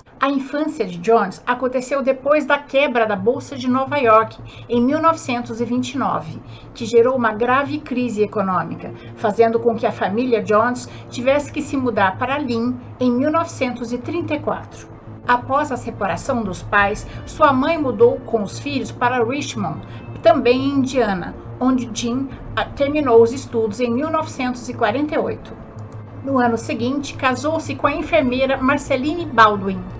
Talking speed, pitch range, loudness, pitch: 135 wpm, 220-275 Hz, -19 LUFS, 245 Hz